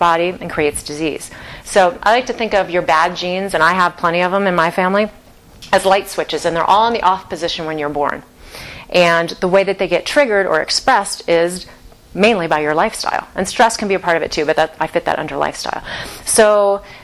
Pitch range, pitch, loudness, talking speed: 165-195 Hz, 180 Hz, -15 LUFS, 230 wpm